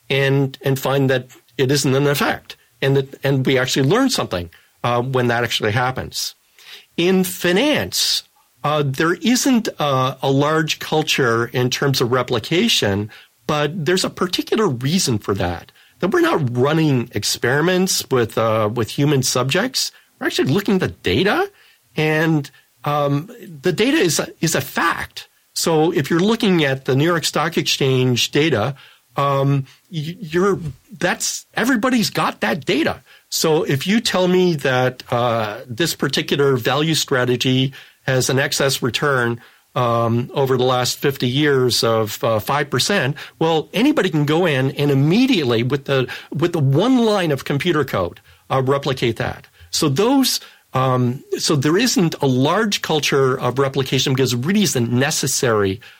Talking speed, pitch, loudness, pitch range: 160 wpm, 140 Hz, -18 LUFS, 125-170 Hz